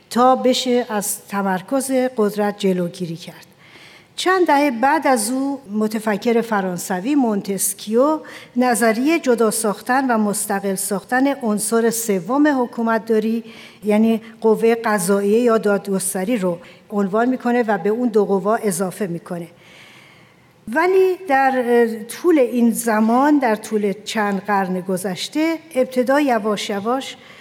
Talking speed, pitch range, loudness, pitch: 115 wpm, 200-255 Hz, -18 LUFS, 225 Hz